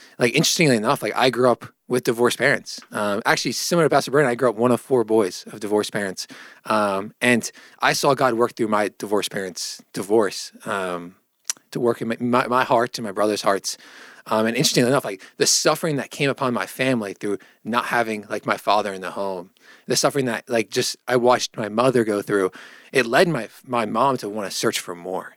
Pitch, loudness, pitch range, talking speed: 120 Hz, -21 LUFS, 105-125 Hz, 220 wpm